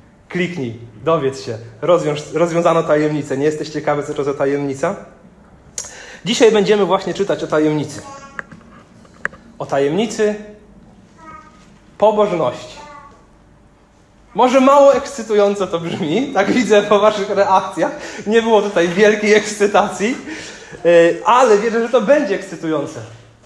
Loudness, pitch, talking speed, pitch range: -15 LUFS, 195 Hz, 110 wpm, 150-215 Hz